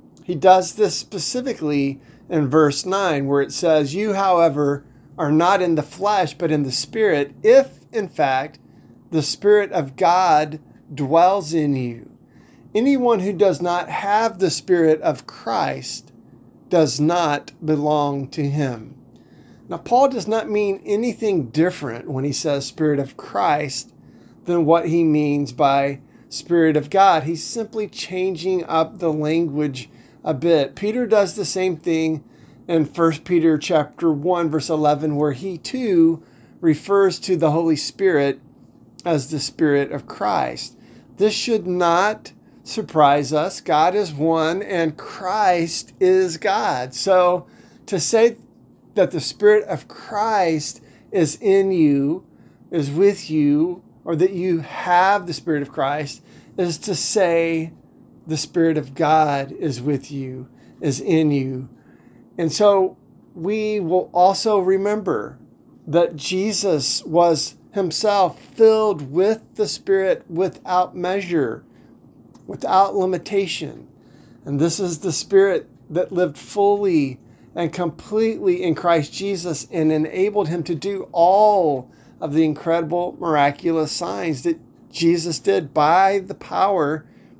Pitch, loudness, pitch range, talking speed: 165 Hz, -20 LUFS, 150-190 Hz, 135 wpm